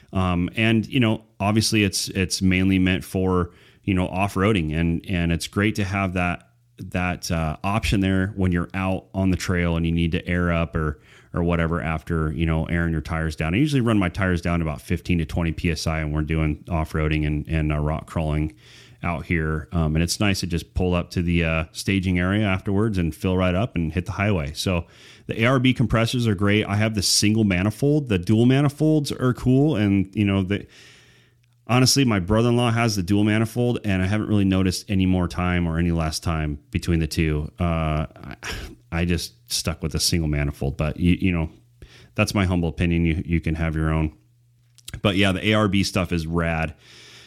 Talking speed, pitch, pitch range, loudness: 205 wpm, 90 Hz, 85-105 Hz, -22 LUFS